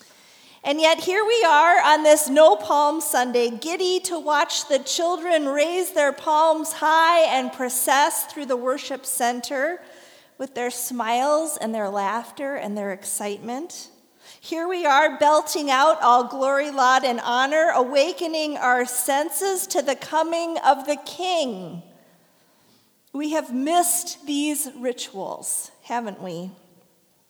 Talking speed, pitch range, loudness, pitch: 130 wpm, 250-315 Hz, -21 LUFS, 280 Hz